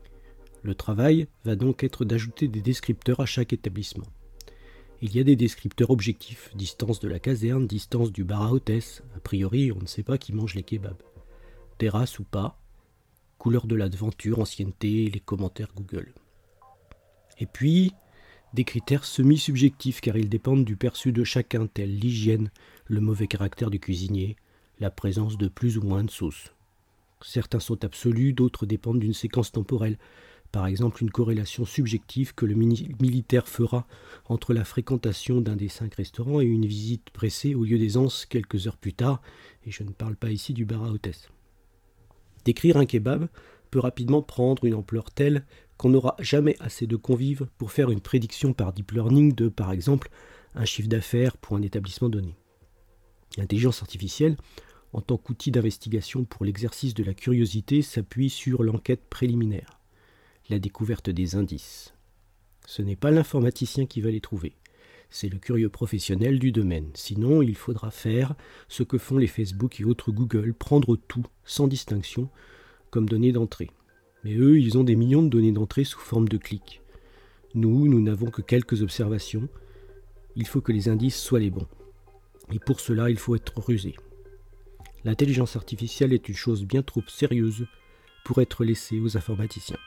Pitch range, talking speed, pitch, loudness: 100-125 Hz, 165 wpm, 115 Hz, -26 LUFS